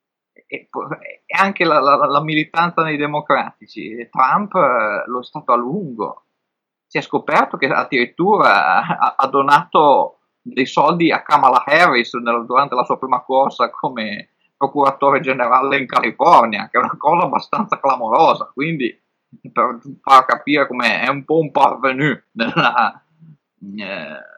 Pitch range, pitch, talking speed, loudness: 135-160 Hz, 145 Hz, 140 wpm, -16 LUFS